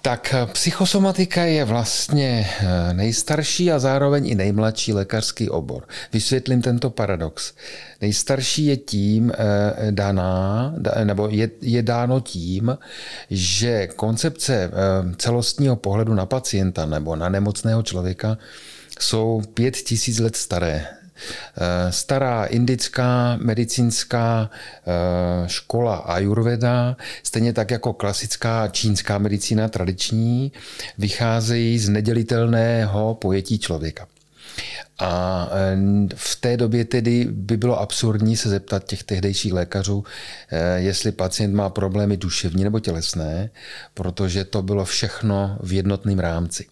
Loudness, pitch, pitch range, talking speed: -21 LUFS, 110 Hz, 95-120 Hz, 105 wpm